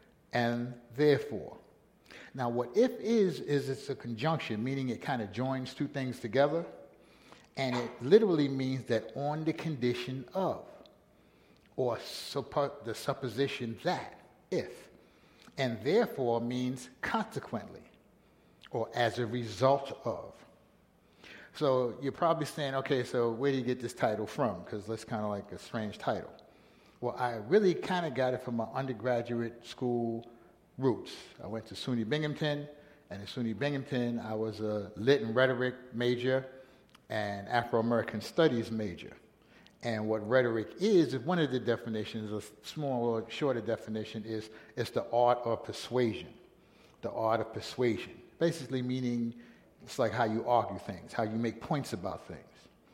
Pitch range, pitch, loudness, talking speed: 115-135 Hz, 120 Hz, -33 LUFS, 150 wpm